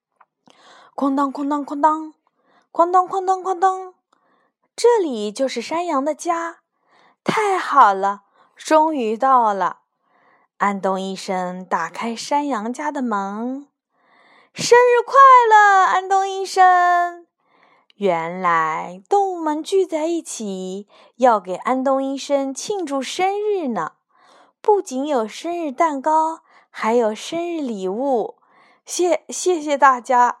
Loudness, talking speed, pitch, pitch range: -18 LUFS, 165 characters per minute, 290 Hz, 235-355 Hz